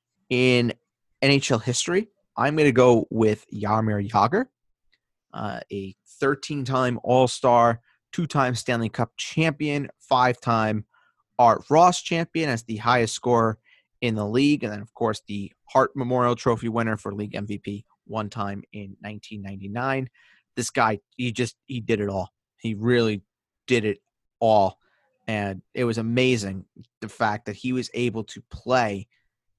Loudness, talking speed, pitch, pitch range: -24 LUFS, 140 wpm, 115 Hz, 105-125 Hz